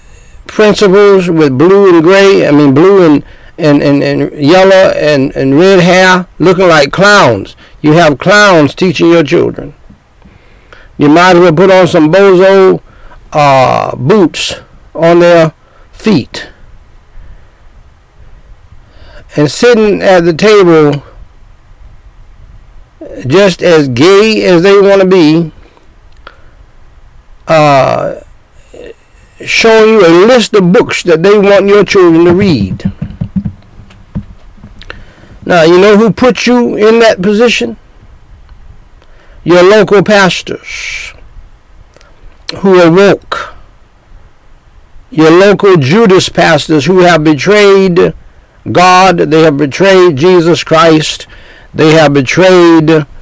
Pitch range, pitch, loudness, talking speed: 155-195 Hz, 180 Hz, -5 LUFS, 110 wpm